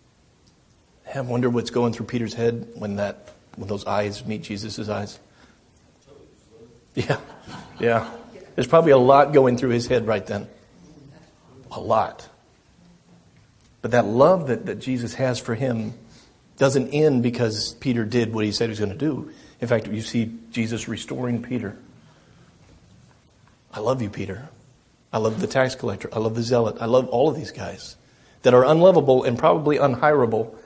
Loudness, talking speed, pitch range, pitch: -22 LUFS, 160 wpm, 110-130 Hz, 120 Hz